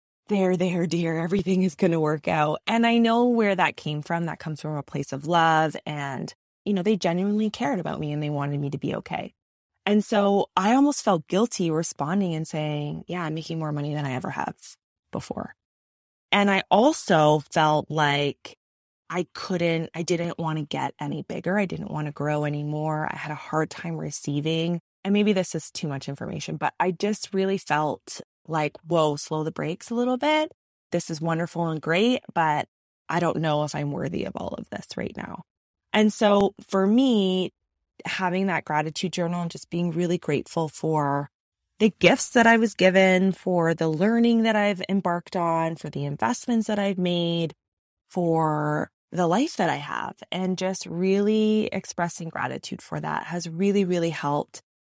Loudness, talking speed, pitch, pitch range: -25 LUFS, 185 wpm, 170 Hz, 155-195 Hz